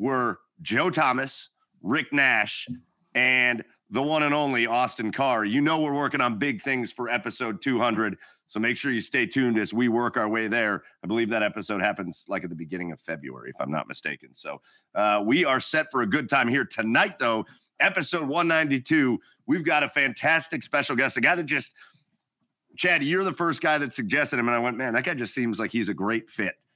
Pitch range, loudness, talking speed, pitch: 105-135 Hz, -25 LUFS, 210 wpm, 120 Hz